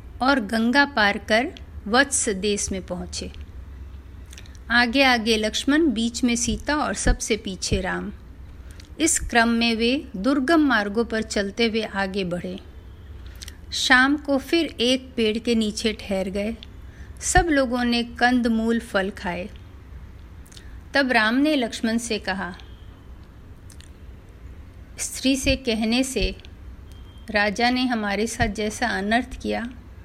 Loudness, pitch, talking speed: -22 LUFS, 215 Hz, 120 wpm